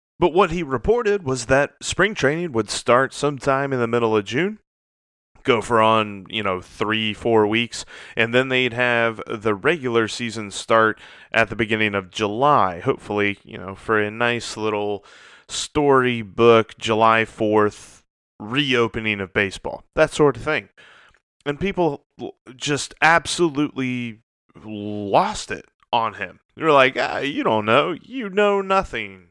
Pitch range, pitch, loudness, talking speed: 105-140 Hz, 115 Hz, -20 LUFS, 145 wpm